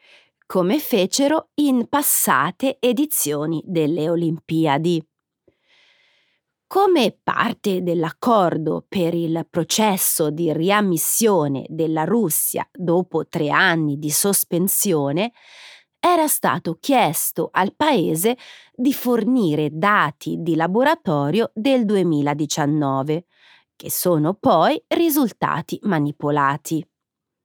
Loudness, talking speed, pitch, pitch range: -19 LUFS, 85 wpm, 175 Hz, 155-235 Hz